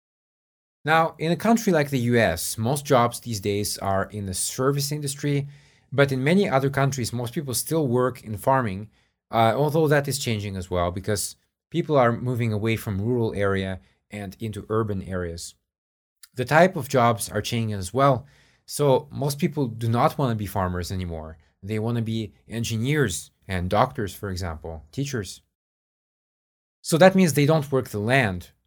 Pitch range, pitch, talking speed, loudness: 100-140 Hz, 115 Hz, 170 wpm, -24 LUFS